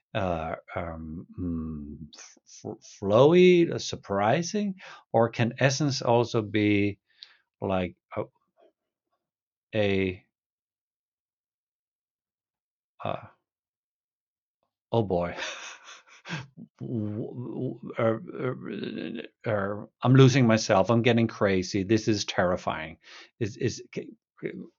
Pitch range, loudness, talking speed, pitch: 95-120 Hz, -26 LUFS, 70 wpm, 110 Hz